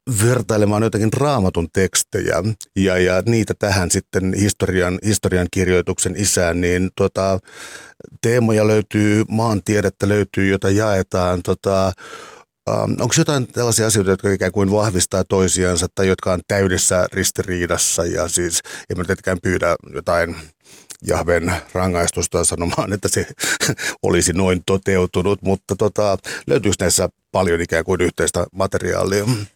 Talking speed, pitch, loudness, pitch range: 120 wpm, 95 Hz, -18 LUFS, 90-105 Hz